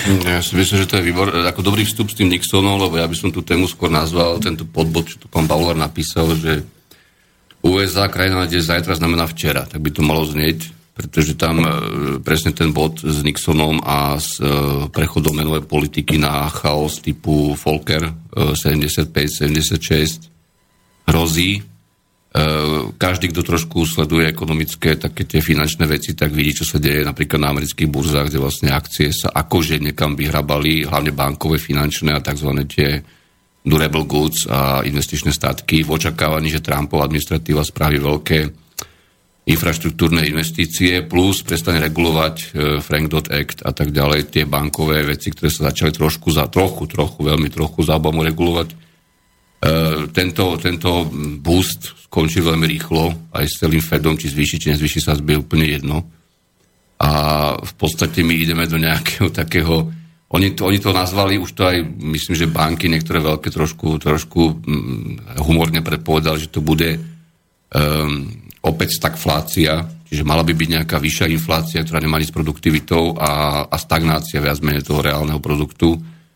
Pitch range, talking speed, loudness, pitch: 75-85 Hz, 155 wpm, -17 LUFS, 80 Hz